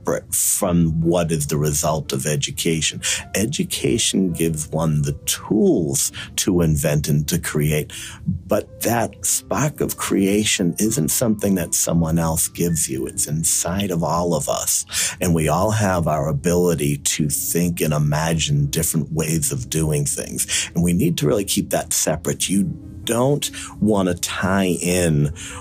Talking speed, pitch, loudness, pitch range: 150 wpm, 85 Hz, -20 LUFS, 75-95 Hz